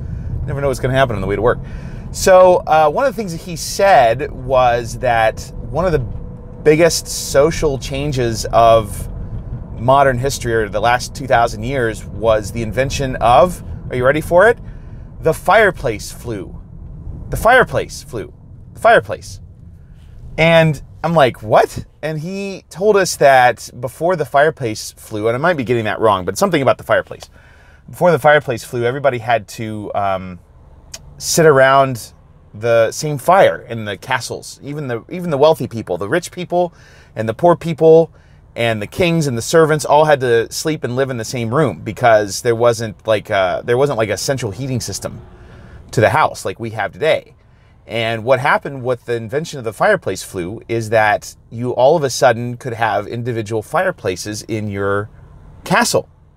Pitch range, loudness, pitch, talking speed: 110-145 Hz, -15 LUFS, 120 Hz, 175 wpm